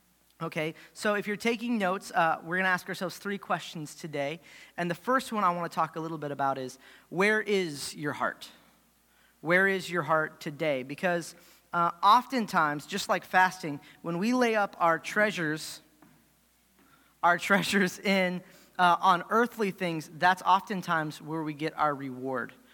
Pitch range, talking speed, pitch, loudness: 160-195 Hz, 165 wpm, 175 Hz, -28 LUFS